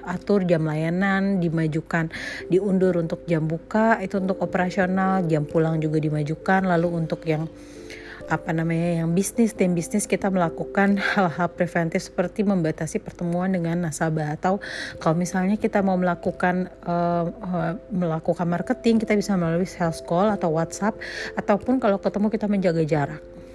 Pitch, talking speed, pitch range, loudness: 175 Hz, 140 wpm, 165-195 Hz, -23 LUFS